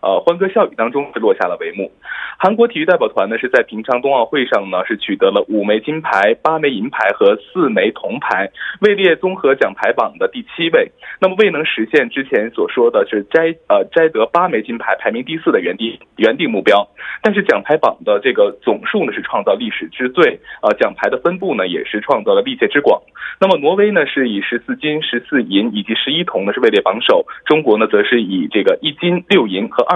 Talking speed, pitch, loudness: 320 characters per minute, 210 Hz, -15 LUFS